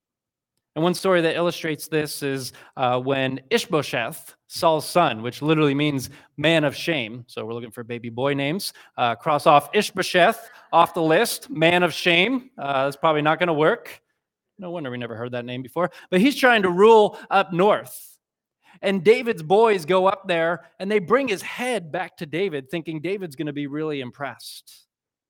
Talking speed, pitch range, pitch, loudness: 180 wpm, 140-185 Hz, 165 Hz, -21 LUFS